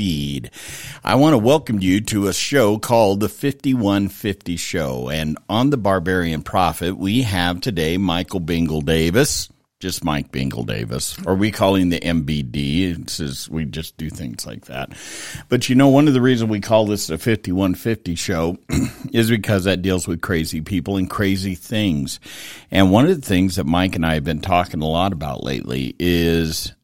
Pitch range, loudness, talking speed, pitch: 80-100 Hz, -19 LUFS, 180 wpm, 95 Hz